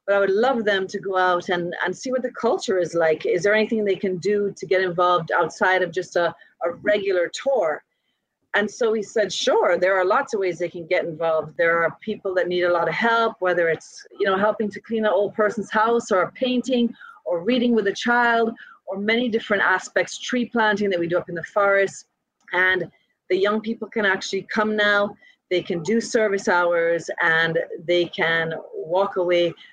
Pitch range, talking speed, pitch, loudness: 175-220 Hz, 210 wpm, 195 Hz, -22 LUFS